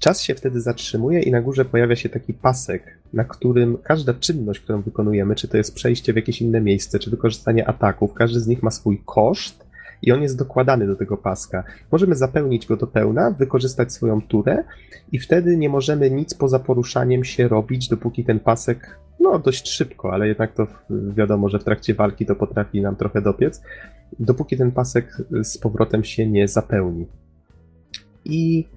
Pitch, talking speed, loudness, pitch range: 115 Hz, 180 wpm, -20 LUFS, 105-130 Hz